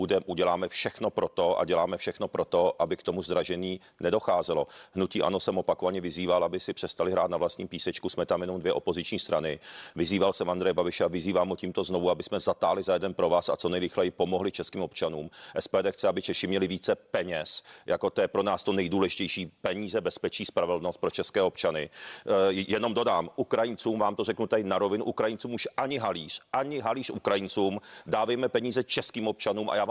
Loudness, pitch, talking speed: -29 LUFS, 125 Hz, 195 wpm